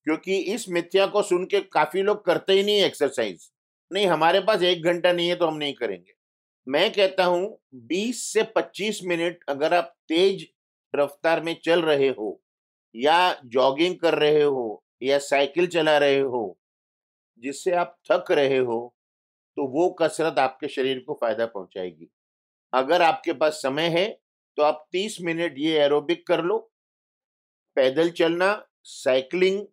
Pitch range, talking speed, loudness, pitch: 140-180 Hz, 155 wpm, -23 LUFS, 165 Hz